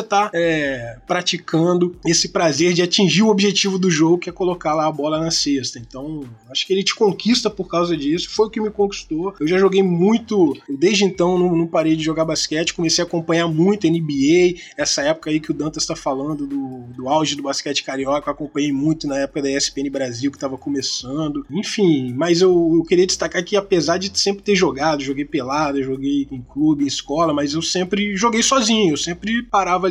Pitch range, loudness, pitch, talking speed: 145-195 Hz, -18 LUFS, 170 Hz, 205 wpm